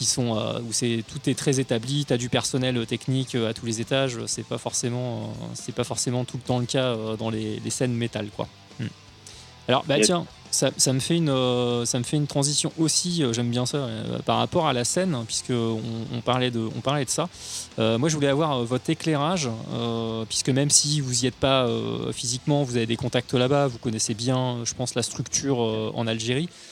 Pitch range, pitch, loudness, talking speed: 115-140 Hz, 125 Hz, -25 LUFS, 205 wpm